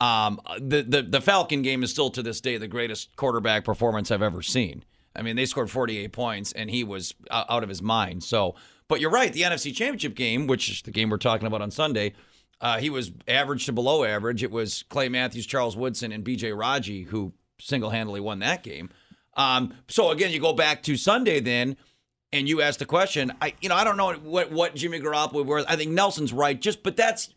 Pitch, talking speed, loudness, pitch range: 125 Hz, 230 wpm, -25 LUFS, 110-145 Hz